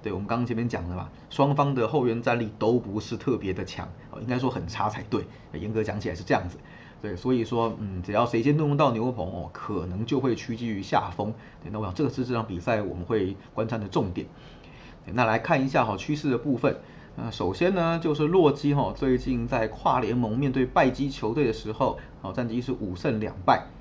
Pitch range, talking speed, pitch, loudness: 105-135 Hz, 320 characters per minute, 120 Hz, -27 LUFS